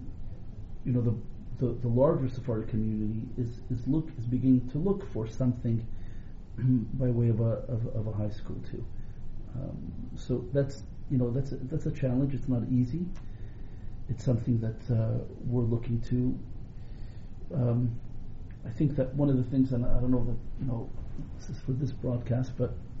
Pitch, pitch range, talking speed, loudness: 120 Hz, 110-130 Hz, 175 wpm, -31 LUFS